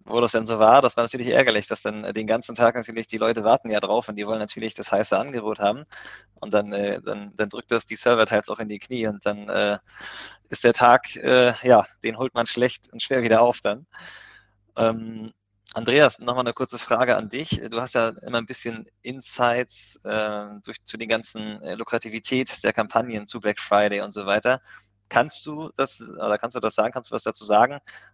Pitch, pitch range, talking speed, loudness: 115 Hz, 105-120 Hz, 215 wpm, -23 LUFS